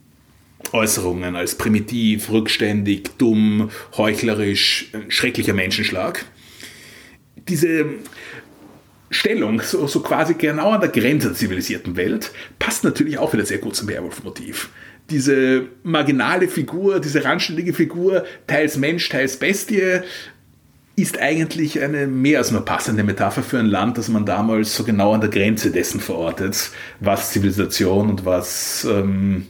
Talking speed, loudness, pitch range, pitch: 130 wpm, -19 LUFS, 105-155 Hz, 115 Hz